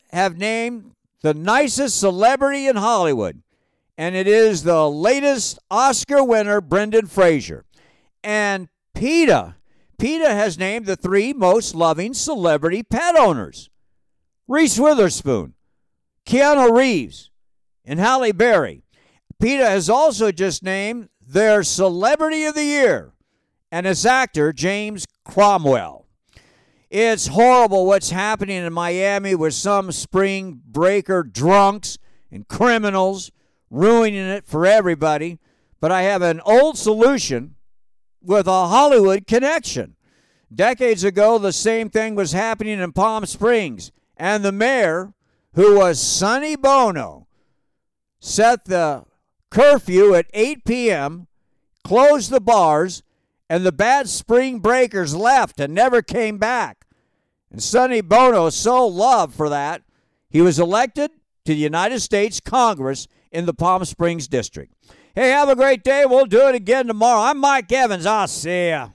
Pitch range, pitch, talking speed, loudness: 180-245 Hz, 210 Hz, 130 wpm, -17 LUFS